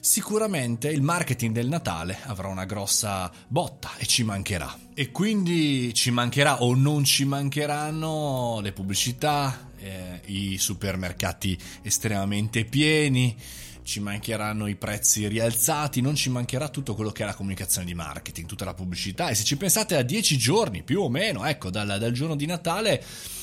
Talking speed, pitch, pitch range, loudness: 160 wpm, 115 Hz, 100-145 Hz, -25 LUFS